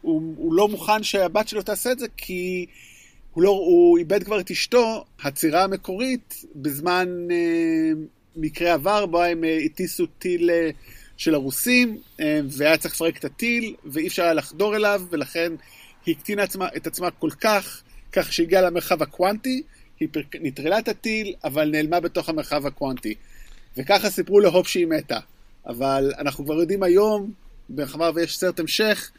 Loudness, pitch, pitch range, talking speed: -22 LUFS, 180 Hz, 160-210 Hz, 160 wpm